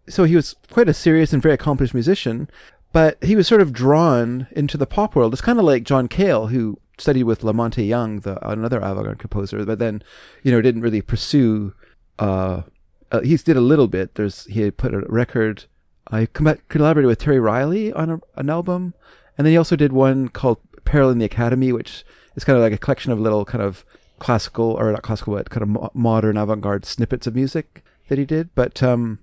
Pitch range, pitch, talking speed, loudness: 110-145 Hz, 125 Hz, 215 wpm, -19 LUFS